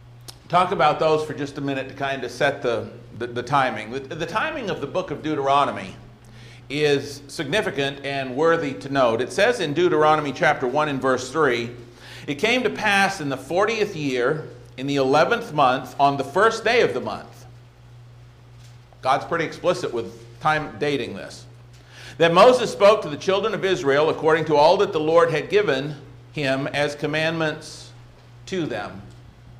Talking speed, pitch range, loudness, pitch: 170 wpm, 120-155 Hz, -21 LUFS, 140 Hz